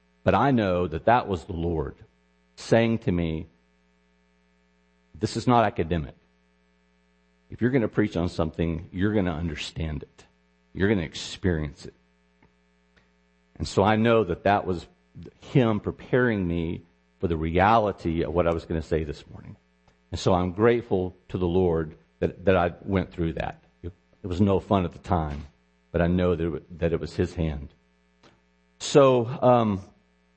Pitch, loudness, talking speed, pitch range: 85 Hz, -25 LUFS, 180 wpm, 60-95 Hz